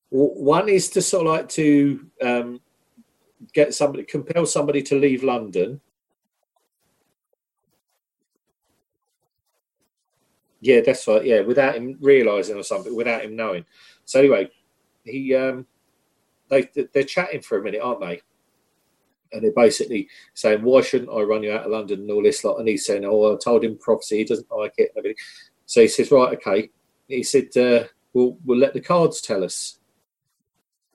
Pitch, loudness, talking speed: 145 Hz, -20 LUFS, 160 wpm